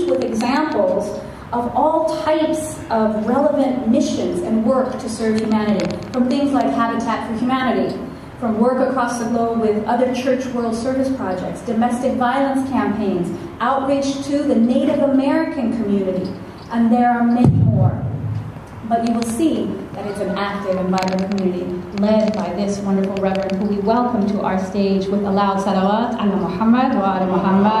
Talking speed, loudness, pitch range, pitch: 160 wpm, -19 LUFS, 195-260 Hz, 230 Hz